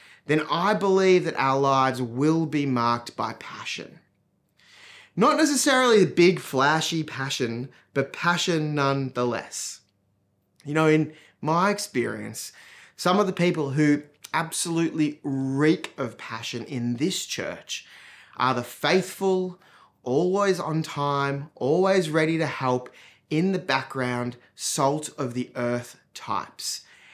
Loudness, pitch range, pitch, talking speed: -24 LUFS, 125-175 Hz, 150 Hz, 120 wpm